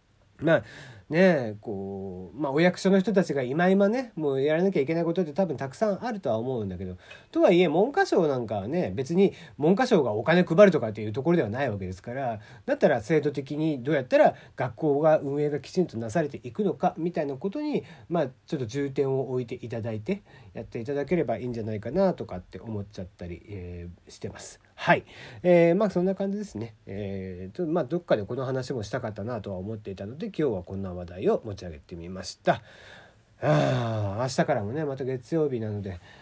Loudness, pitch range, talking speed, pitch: -26 LUFS, 105-170 Hz, 425 characters per minute, 135 Hz